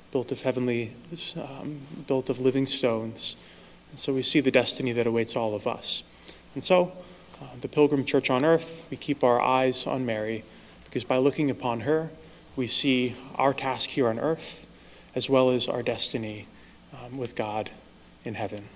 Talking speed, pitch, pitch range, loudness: 175 wpm, 130 Hz, 115-145 Hz, -27 LUFS